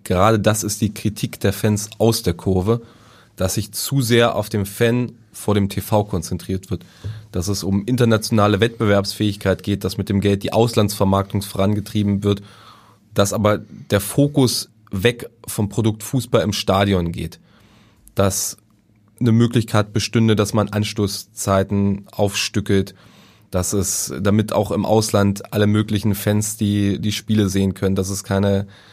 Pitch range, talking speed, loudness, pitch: 100-110 Hz, 150 wpm, -19 LUFS, 105 Hz